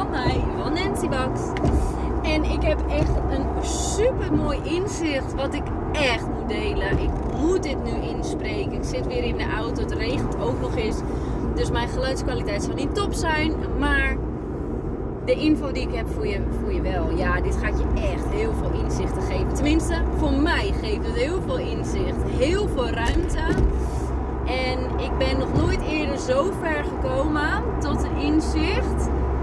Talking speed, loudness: 170 wpm, -24 LUFS